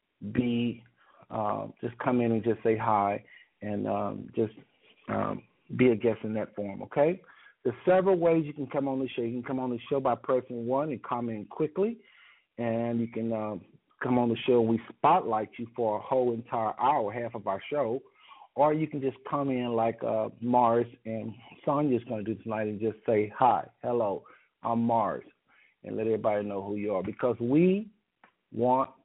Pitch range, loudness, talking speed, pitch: 110-130 Hz, -29 LUFS, 195 wpm, 120 Hz